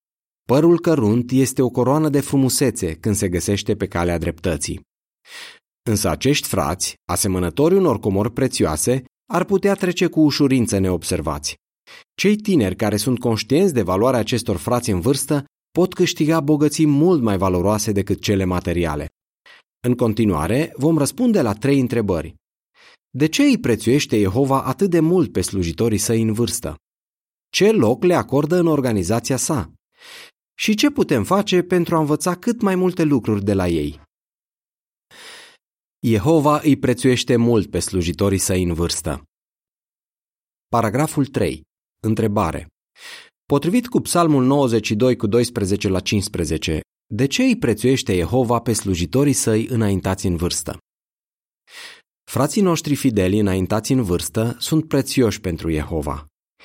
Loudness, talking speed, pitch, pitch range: -19 LUFS, 135 wpm, 120 Hz, 95-150 Hz